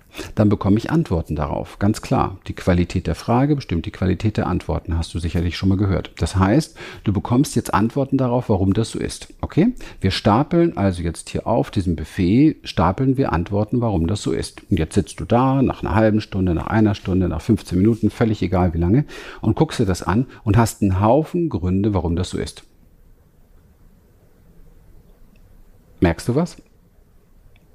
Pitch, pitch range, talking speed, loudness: 100 Hz, 90-115 Hz, 185 wpm, -20 LUFS